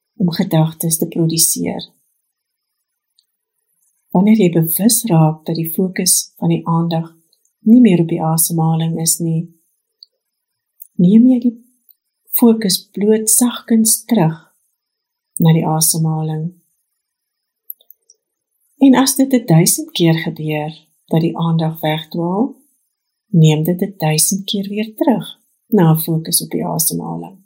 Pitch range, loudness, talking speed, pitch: 165-230 Hz, -14 LUFS, 120 wpm, 175 Hz